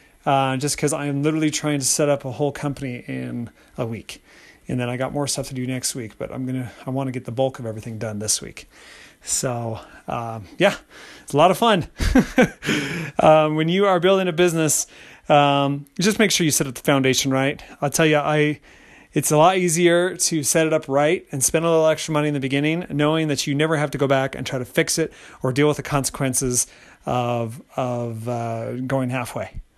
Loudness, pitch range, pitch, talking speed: -21 LUFS, 130-155 Hz, 140 Hz, 220 wpm